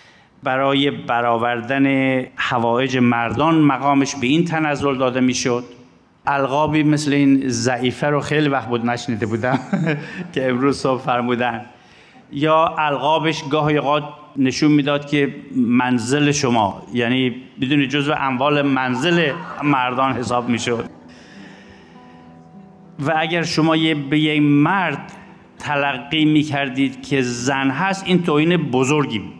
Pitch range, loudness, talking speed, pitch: 125-150 Hz, -18 LUFS, 120 wpm, 140 Hz